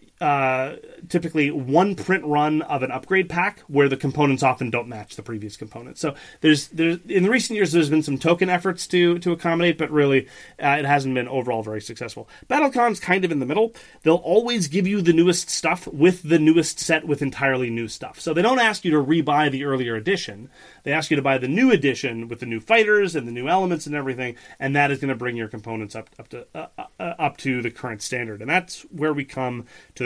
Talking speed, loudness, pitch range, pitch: 230 wpm, -21 LUFS, 130-175 Hz, 150 Hz